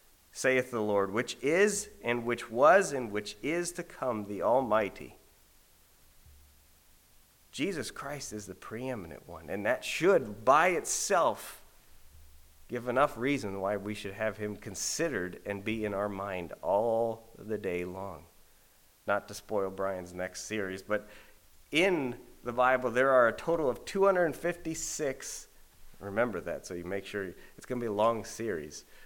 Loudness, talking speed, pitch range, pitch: -31 LUFS, 150 wpm, 90-125 Hz, 105 Hz